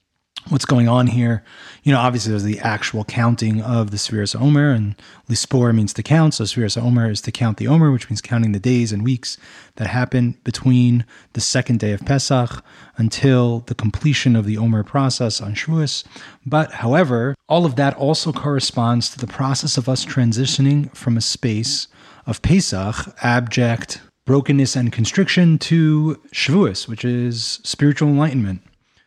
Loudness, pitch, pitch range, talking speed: -18 LUFS, 120 Hz, 115-140 Hz, 165 wpm